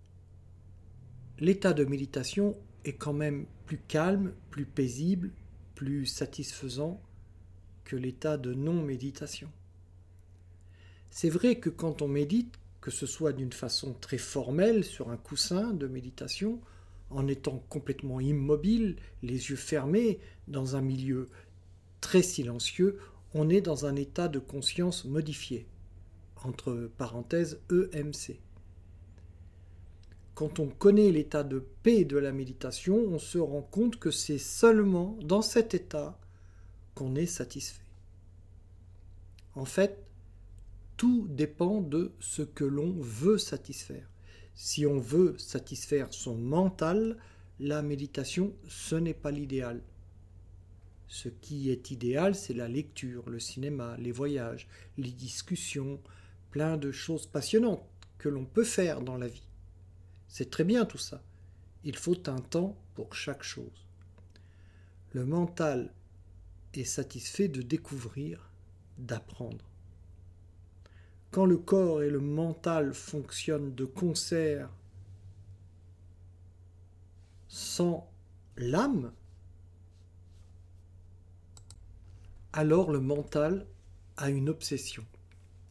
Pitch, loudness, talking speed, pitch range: 130 Hz, -32 LUFS, 115 wpm, 90-150 Hz